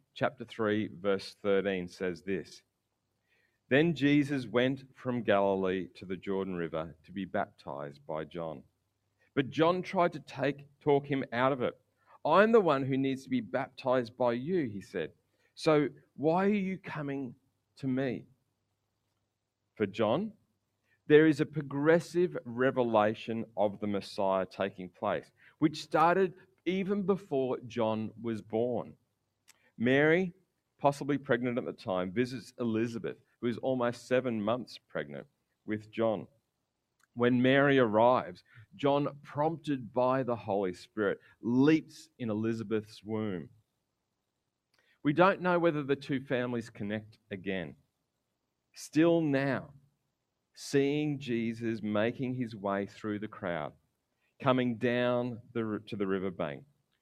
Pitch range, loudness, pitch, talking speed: 105-140 Hz, -31 LUFS, 125 Hz, 130 wpm